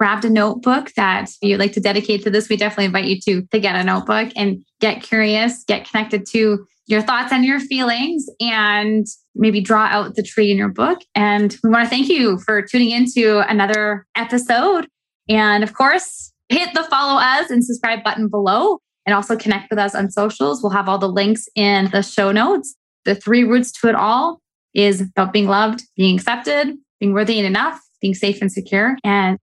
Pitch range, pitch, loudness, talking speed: 200-240 Hz, 215 Hz, -17 LUFS, 200 wpm